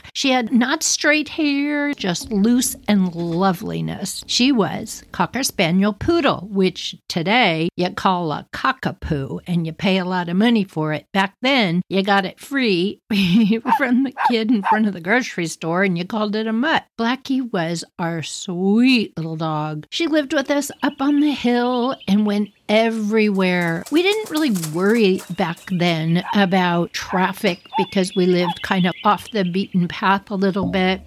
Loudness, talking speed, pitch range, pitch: -19 LUFS, 170 wpm, 180-245 Hz, 200 Hz